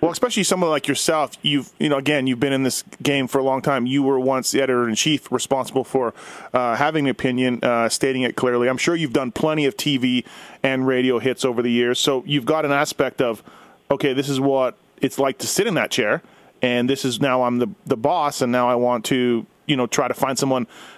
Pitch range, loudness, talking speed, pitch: 125-140 Hz, -20 LUFS, 240 wpm, 135 Hz